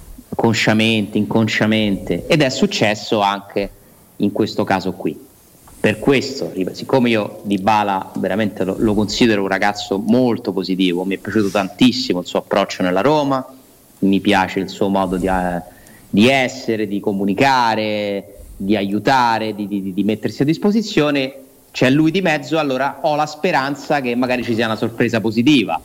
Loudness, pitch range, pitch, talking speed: -17 LUFS, 100-125 Hz, 110 Hz, 155 wpm